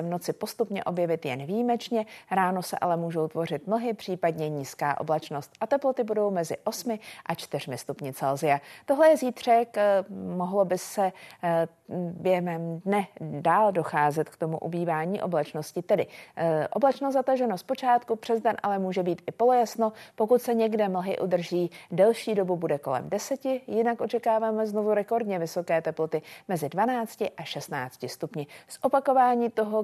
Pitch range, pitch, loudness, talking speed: 165-225 Hz, 190 Hz, -27 LUFS, 150 wpm